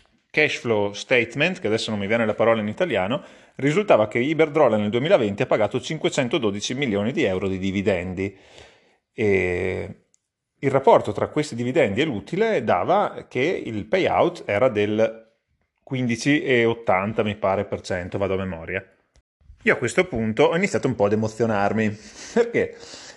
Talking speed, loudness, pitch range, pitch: 150 wpm, -22 LUFS, 100-130 Hz, 110 Hz